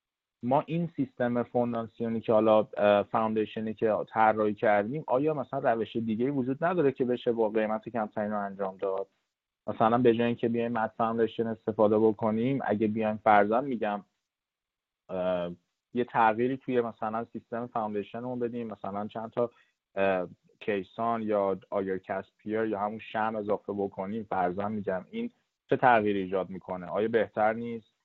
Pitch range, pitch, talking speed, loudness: 105-120 Hz, 110 Hz, 145 wpm, -29 LUFS